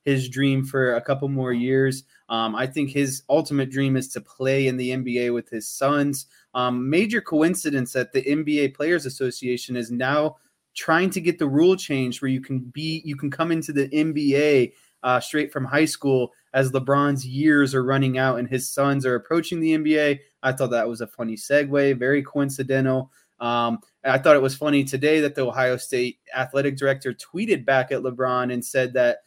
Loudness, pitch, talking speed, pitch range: -22 LUFS, 135 Hz, 195 wpm, 130-145 Hz